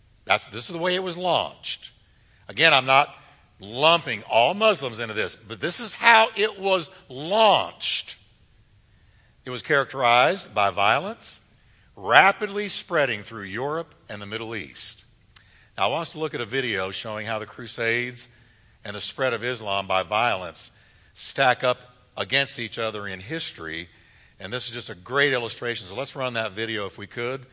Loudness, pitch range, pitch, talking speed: -23 LUFS, 105-135 Hz, 115 Hz, 170 wpm